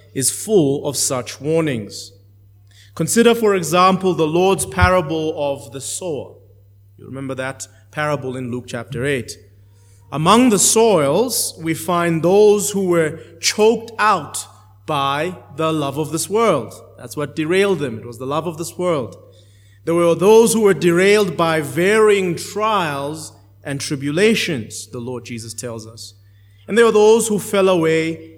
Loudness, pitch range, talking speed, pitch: -17 LUFS, 115-185 Hz, 150 wpm, 150 Hz